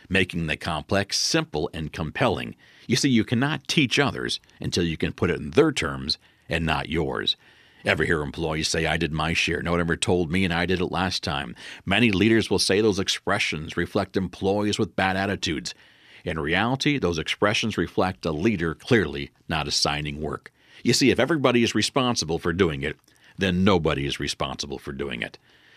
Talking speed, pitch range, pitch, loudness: 185 wpm, 80-110 Hz, 90 Hz, -24 LUFS